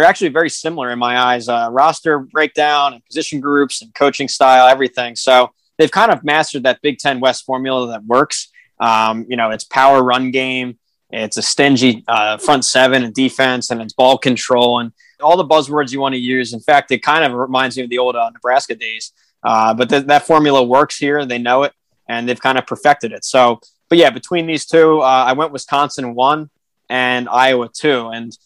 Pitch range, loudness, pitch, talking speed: 120-145 Hz, -14 LUFS, 130 Hz, 210 wpm